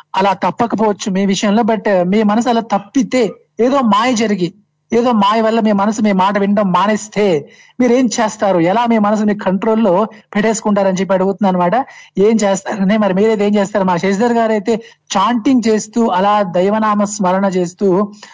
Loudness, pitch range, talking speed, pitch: -14 LUFS, 195-225 Hz, 165 wpm, 210 Hz